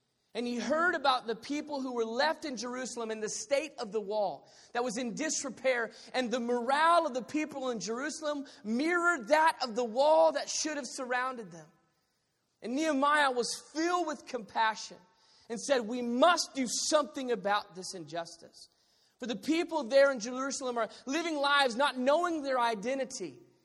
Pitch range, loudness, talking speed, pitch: 230-295 Hz, -31 LUFS, 170 wpm, 255 Hz